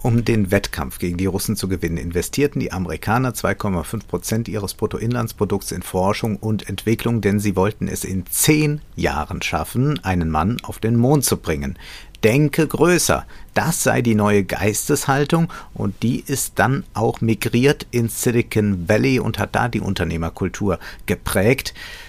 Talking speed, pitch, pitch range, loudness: 150 wpm, 110 Hz, 95-120 Hz, -20 LUFS